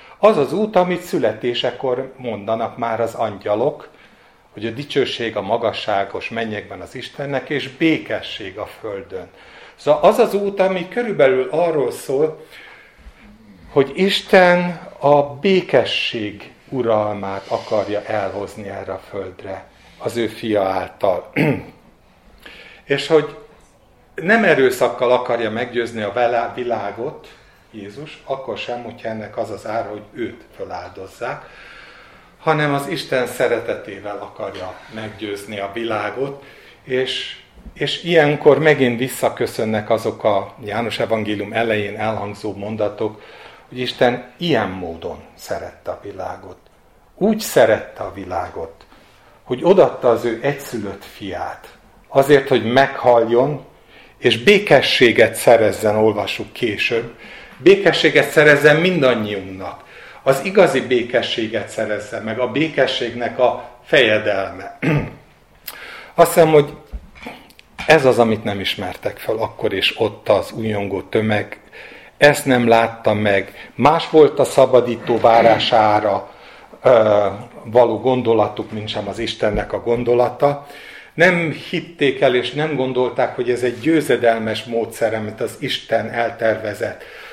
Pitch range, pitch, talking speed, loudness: 110-150 Hz, 125 Hz, 115 wpm, -17 LUFS